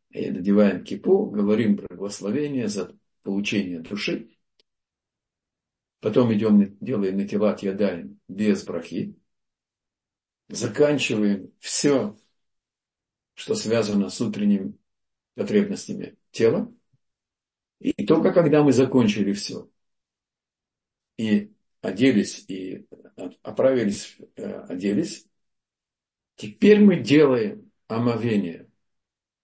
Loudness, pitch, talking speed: -23 LUFS, 115 Hz, 80 wpm